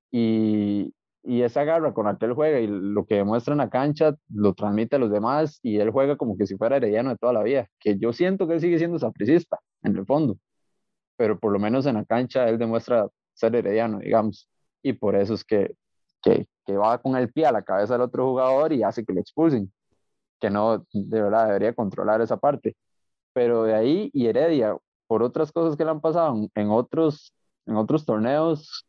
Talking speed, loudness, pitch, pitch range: 215 wpm, -23 LUFS, 120 Hz, 105-145 Hz